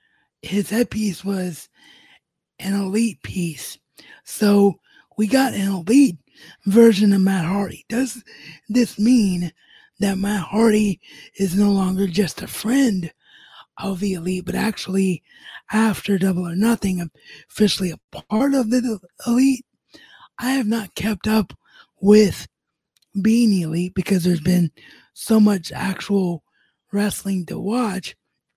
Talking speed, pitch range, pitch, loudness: 125 wpm, 185-225 Hz, 200 Hz, -20 LUFS